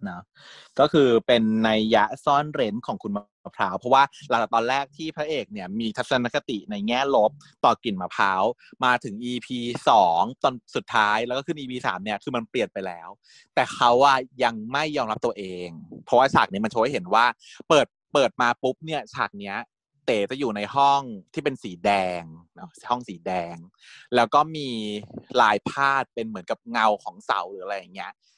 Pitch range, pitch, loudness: 105-140 Hz, 120 Hz, -23 LUFS